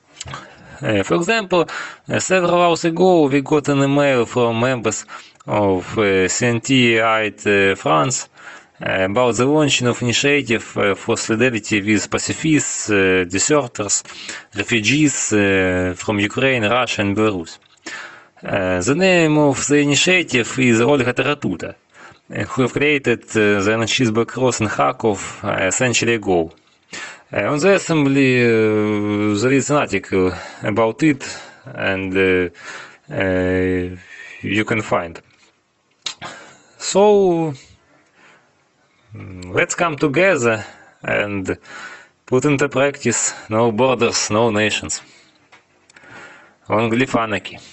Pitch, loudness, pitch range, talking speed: 115 Hz, -17 LUFS, 100-140 Hz, 115 wpm